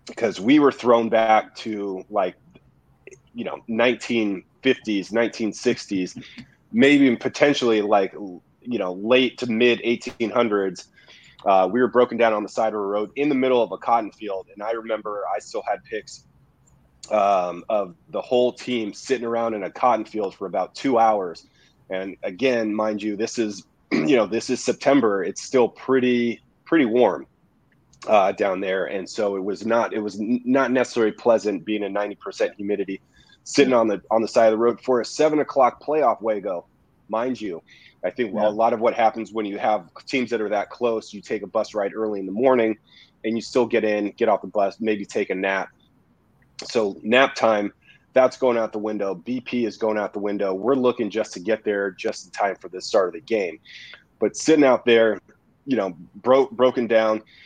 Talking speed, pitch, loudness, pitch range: 200 wpm, 115 Hz, -22 LUFS, 105-125 Hz